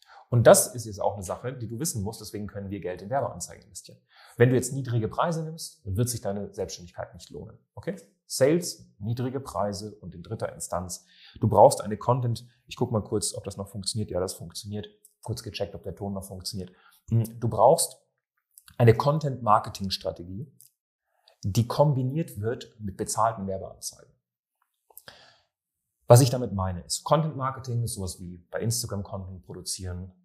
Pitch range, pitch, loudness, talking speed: 95-120 Hz, 105 Hz, -27 LUFS, 175 wpm